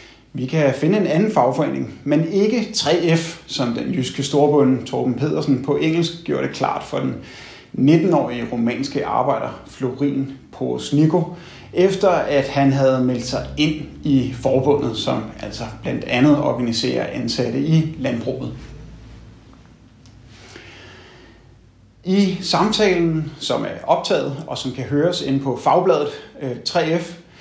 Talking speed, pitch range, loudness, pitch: 125 wpm, 125-165 Hz, -19 LUFS, 140 Hz